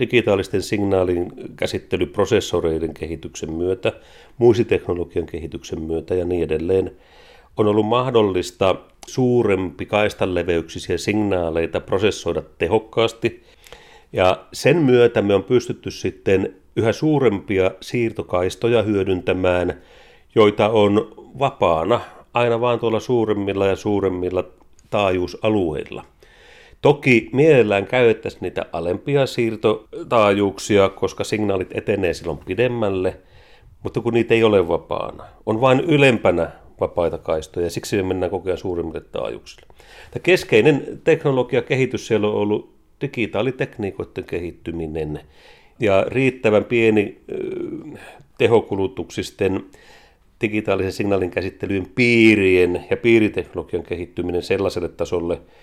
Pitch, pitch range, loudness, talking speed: 105 Hz, 95-120 Hz, -20 LUFS, 95 wpm